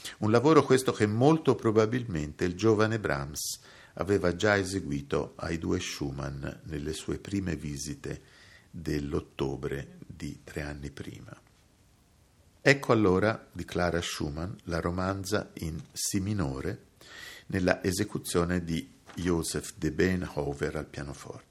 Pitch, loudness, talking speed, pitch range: 90 Hz, -29 LUFS, 120 wpm, 75-105 Hz